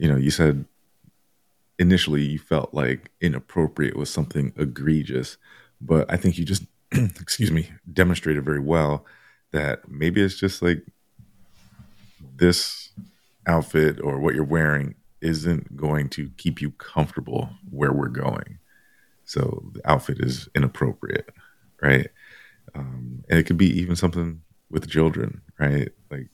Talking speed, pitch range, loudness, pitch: 135 wpm, 75-90 Hz, -23 LUFS, 80 Hz